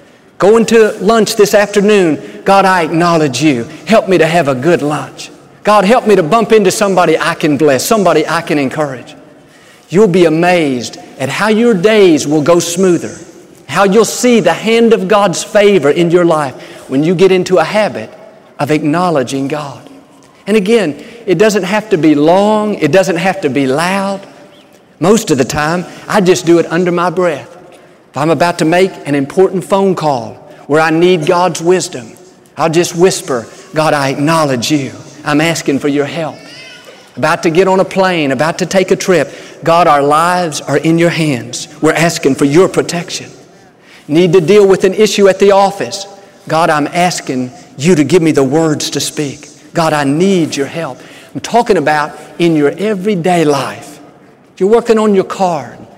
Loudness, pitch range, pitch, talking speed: -11 LUFS, 150-190 Hz, 170 Hz, 185 wpm